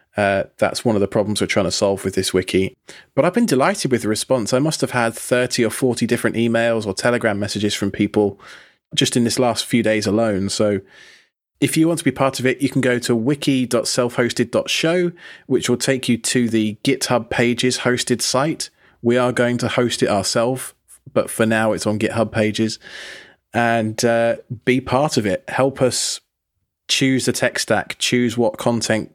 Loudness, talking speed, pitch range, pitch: -19 LUFS, 195 wpm, 110-130 Hz, 120 Hz